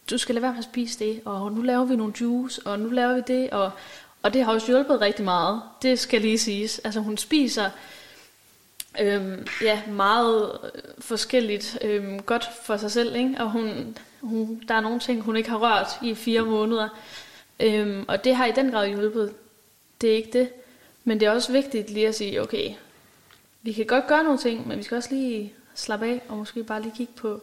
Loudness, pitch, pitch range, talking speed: -25 LUFS, 225 Hz, 215-245 Hz, 210 wpm